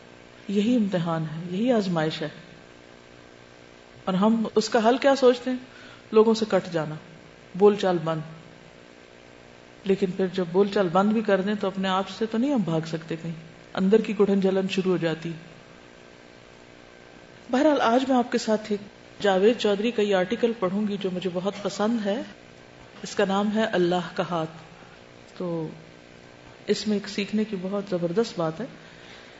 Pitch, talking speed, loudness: 185 Hz, 165 wpm, -25 LUFS